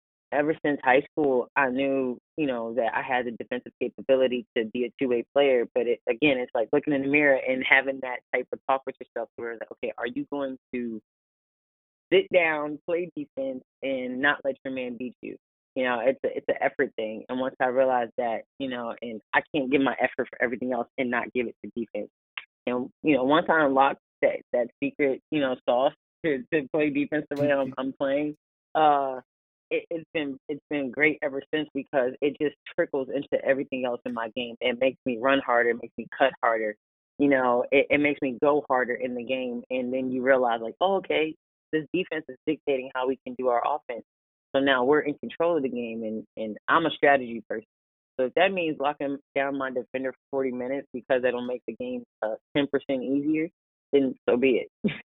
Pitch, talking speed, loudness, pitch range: 130 Hz, 220 wpm, -26 LUFS, 125-145 Hz